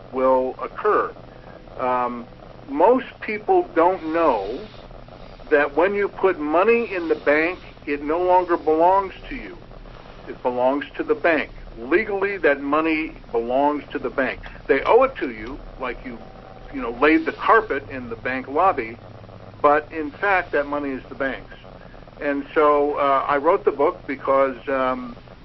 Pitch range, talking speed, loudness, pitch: 130-175 Hz, 155 wpm, -21 LUFS, 145 Hz